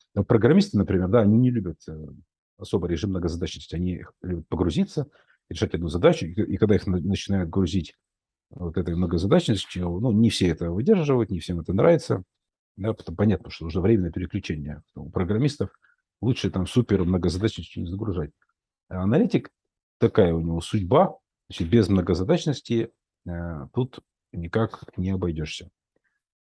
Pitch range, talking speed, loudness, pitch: 85-110 Hz, 140 wpm, -24 LUFS, 95 Hz